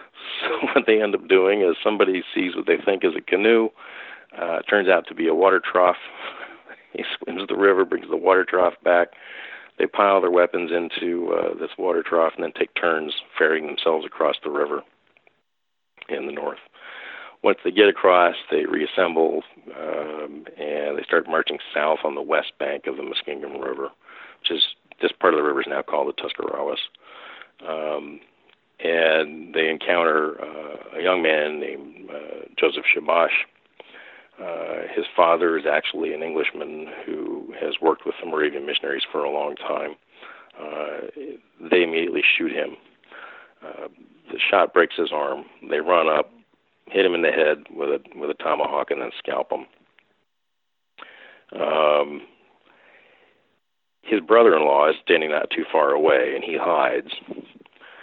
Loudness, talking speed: -21 LUFS, 165 wpm